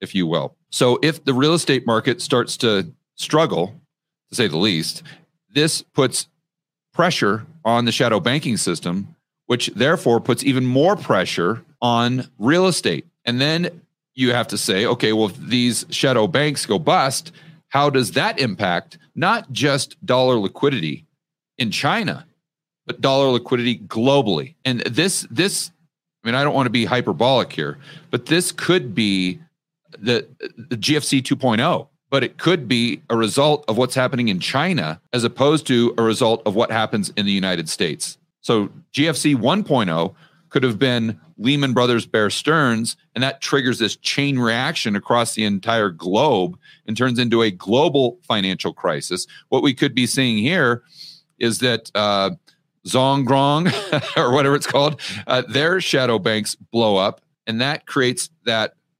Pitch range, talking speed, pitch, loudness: 120-155 Hz, 160 wpm, 135 Hz, -19 LUFS